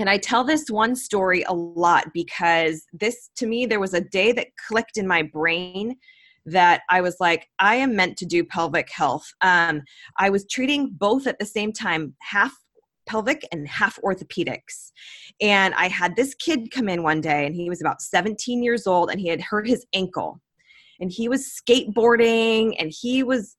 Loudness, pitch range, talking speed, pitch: -22 LUFS, 175-240 Hz, 190 wpm, 200 Hz